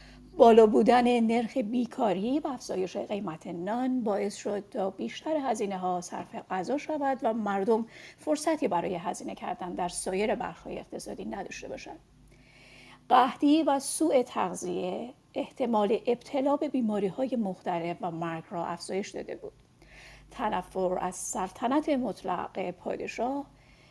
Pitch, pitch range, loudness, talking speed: 220 Hz, 185-260 Hz, -29 LUFS, 125 wpm